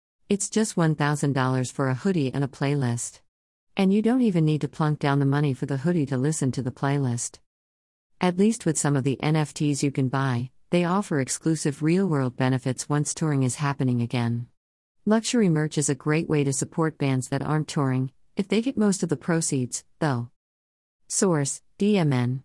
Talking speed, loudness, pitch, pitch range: 185 wpm, -25 LUFS, 145 Hz, 130-160 Hz